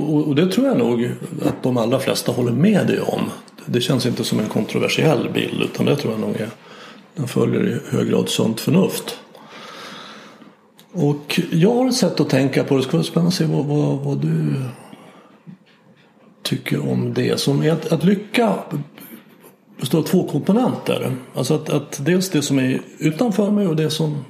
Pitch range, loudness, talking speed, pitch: 145-205 Hz, -19 LUFS, 185 wpm, 160 Hz